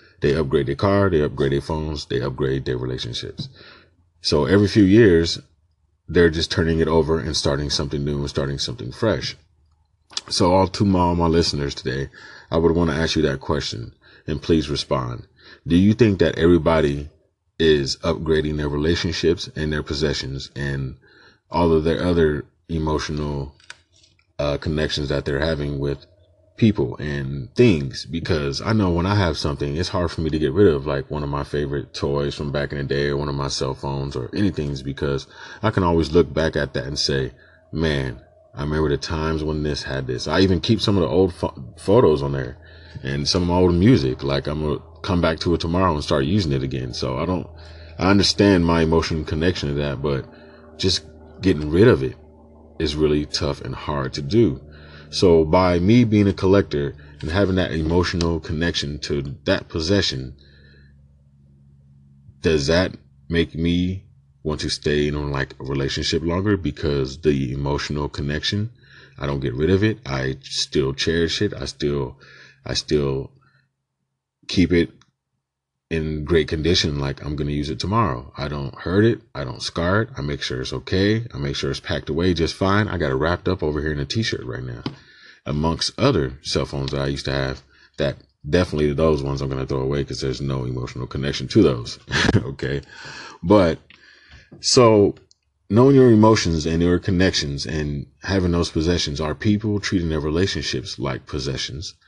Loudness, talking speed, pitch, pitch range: -21 LUFS, 185 wpm, 80 Hz, 70-90 Hz